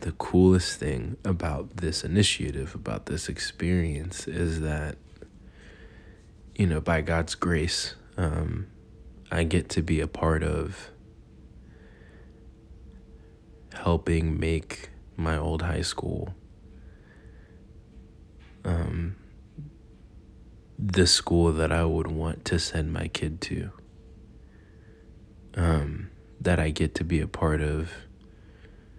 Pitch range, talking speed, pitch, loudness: 80-90 Hz, 105 wpm, 80 Hz, -27 LUFS